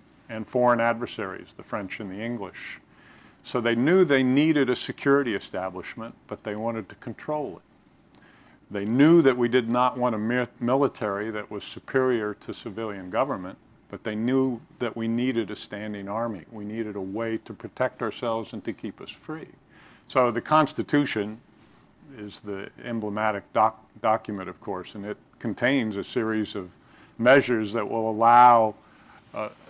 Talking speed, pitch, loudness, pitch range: 160 wpm, 115 Hz, -25 LUFS, 105-125 Hz